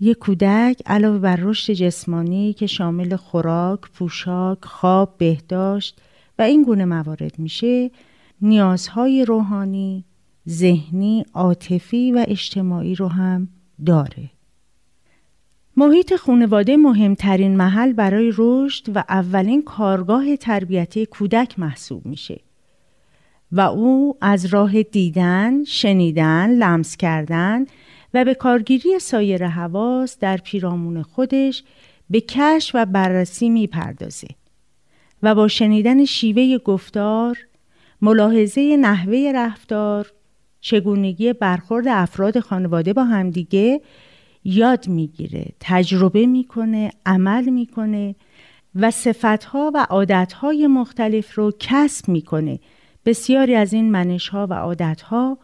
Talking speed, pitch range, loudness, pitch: 105 wpm, 180-235 Hz, -18 LUFS, 205 Hz